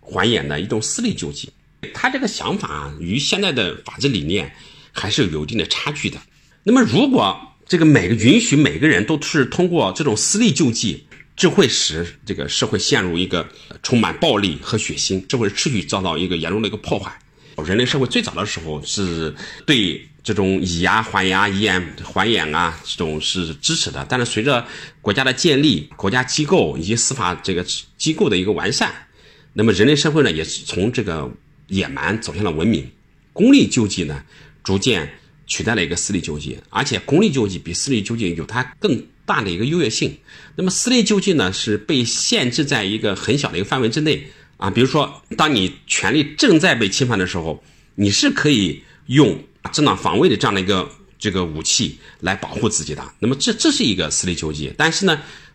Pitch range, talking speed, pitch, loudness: 90-145 Hz, 300 characters per minute, 105 Hz, -18 LUFS